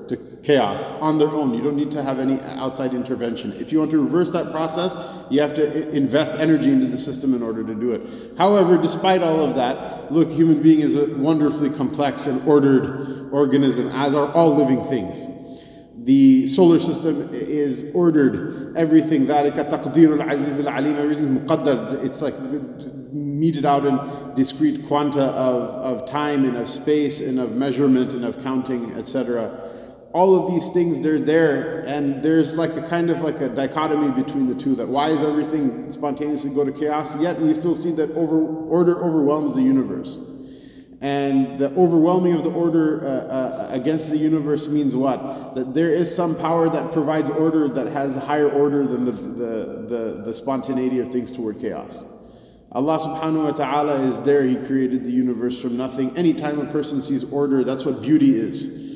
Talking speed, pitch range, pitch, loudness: 175 wpm, 135-160 Hz, 145 Hz, -20 LUFS